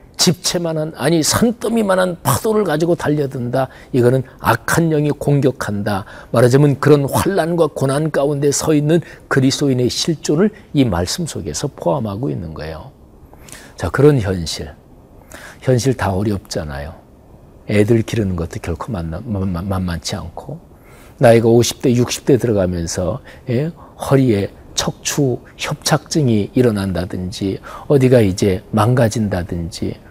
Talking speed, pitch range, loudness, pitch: 285 characters per minute, 100-145 Hz, -17 LUFS, 125 Hz